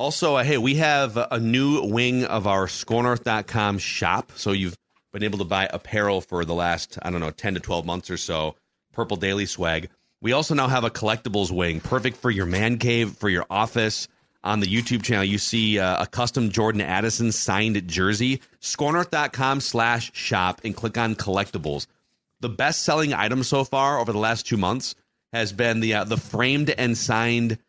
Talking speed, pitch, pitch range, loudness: 190 wpm, 110 Hz, 100-120 Hz, -23 LUFS